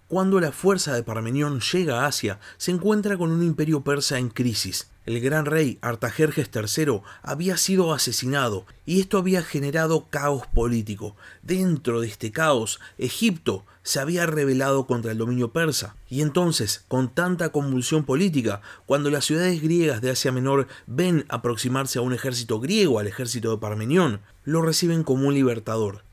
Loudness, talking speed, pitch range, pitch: -23 LUFS, 160 wpm, 120-160 Hz, 135 Hz